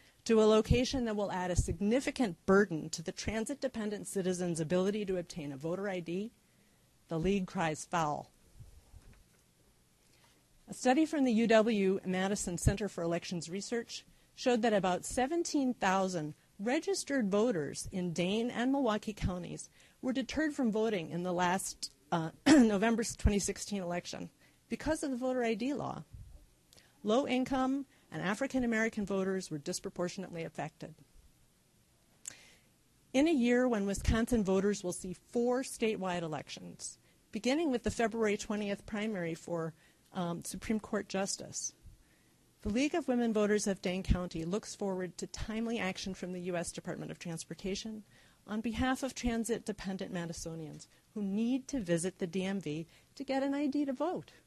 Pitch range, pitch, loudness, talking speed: 175-235 Hz, 200 Hz, -34 LUFS, 145 wpm